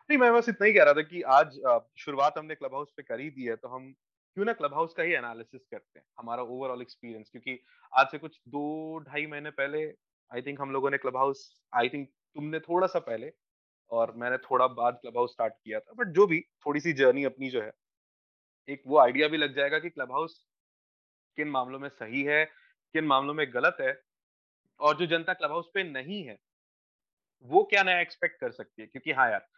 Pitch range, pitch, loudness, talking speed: 125-170 Hz, 145 Hz, -28 LUFS, 220 wpm